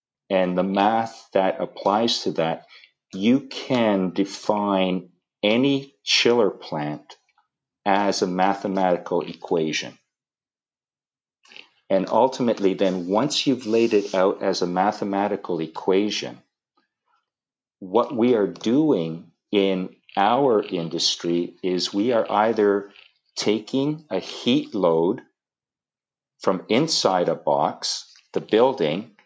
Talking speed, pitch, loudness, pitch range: 105 wpm, 100 Hz, -22 LUFS, 90-105 Hz